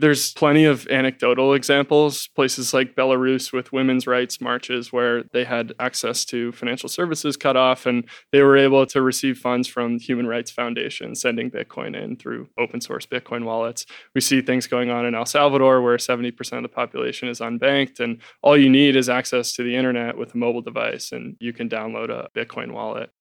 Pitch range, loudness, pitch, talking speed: 120-135 Hz, -20 LUFS, 125 Hz, 195 wpm